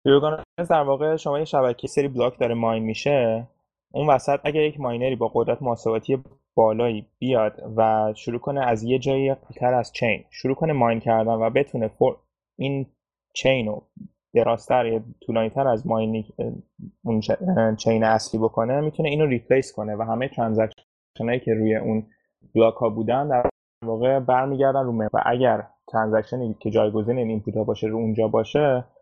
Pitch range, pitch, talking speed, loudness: 110-135 Hz, 120 Hz, 160 wpm, -23 LUFS